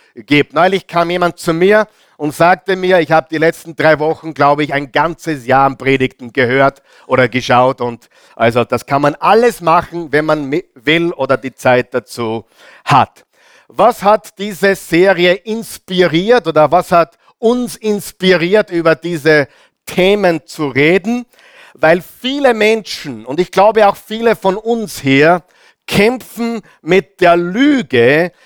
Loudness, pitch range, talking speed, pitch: -13 LUFS, 145-200 Hz, 150 wpm, 170 Hz